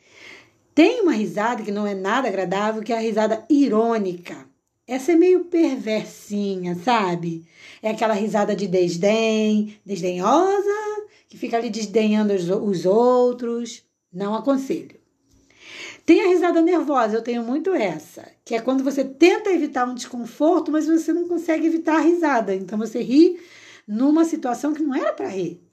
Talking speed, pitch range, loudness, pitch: 150 wpm, 210-320 Hz, -21 LUFS, 240 Hz